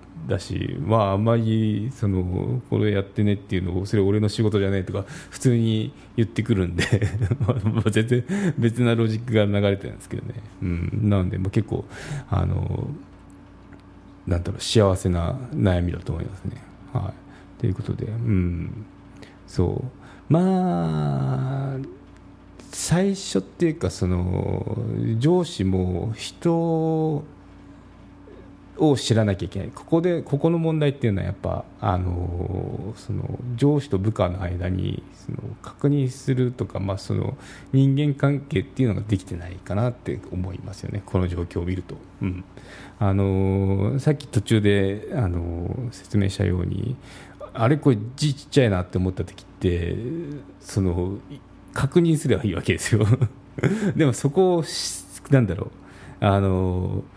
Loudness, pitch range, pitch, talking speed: -24 LUFS, 95-125 Hz, 105 Hz, 285 characters per minute